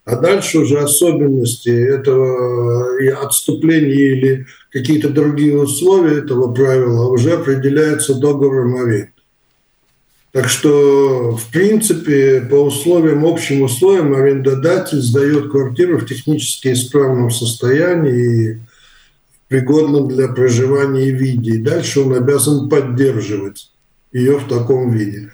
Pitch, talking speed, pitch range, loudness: 135 Hz, 110 wpm, 125-145 Hz, -13 LUFS